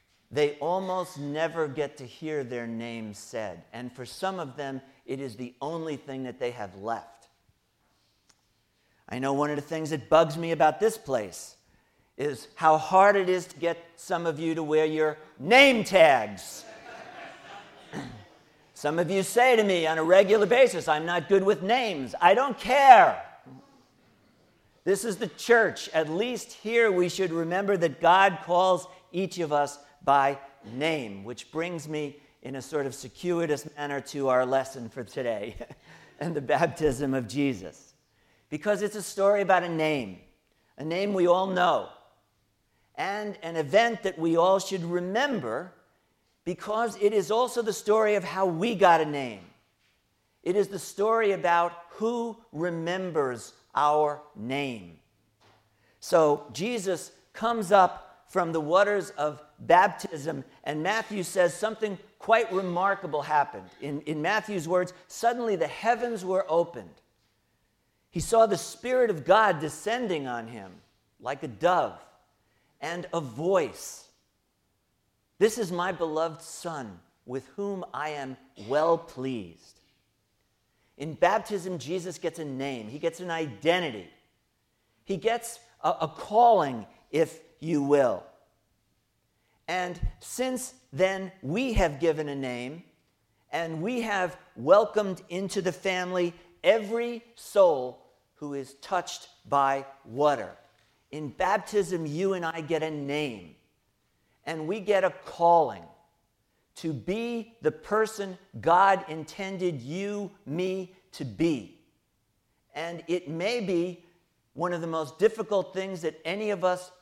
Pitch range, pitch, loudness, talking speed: 145-195 Hz, 170 Hz, -27 LUFS, 140 wpm